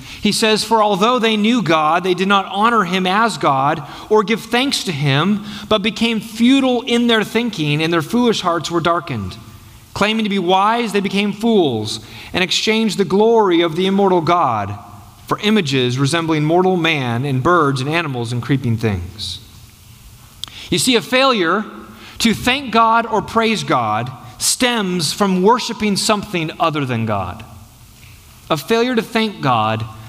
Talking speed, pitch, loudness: 160 wpm, 180 Hz, -16 LUFS